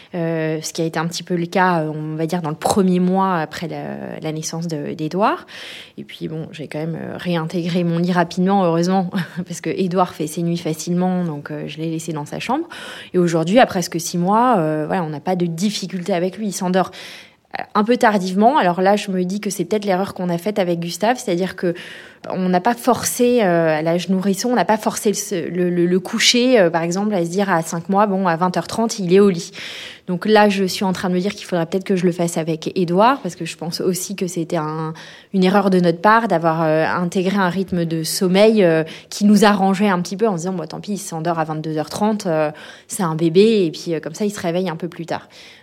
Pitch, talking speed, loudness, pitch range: 180 Hz, 250 wpm, -19 LUFS, 165-200 Hz